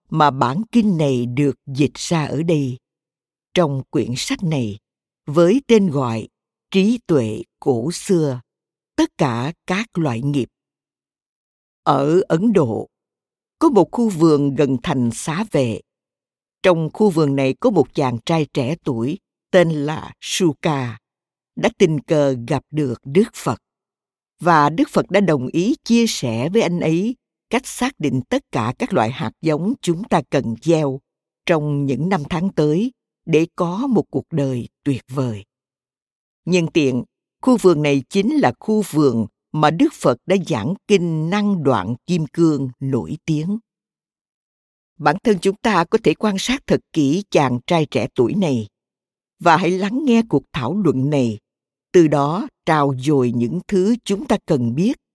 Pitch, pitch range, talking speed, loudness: 160 Hz, 135-195 Hz, 160 wpm, -19 LUFS